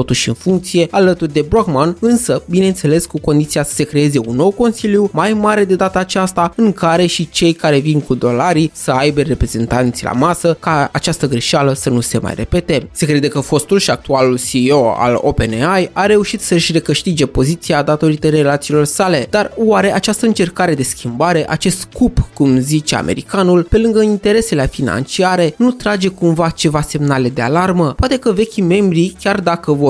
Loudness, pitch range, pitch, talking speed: -13 LUFS, 145-190 Hz, 165 Hz, 175 wpm